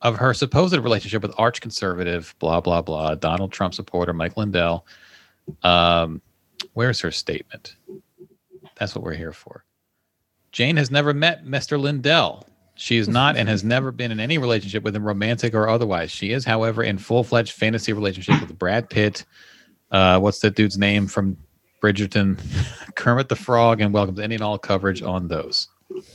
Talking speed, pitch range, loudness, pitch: 170 wpm, 95-120 Hz, -21 LUFS, 110 Hz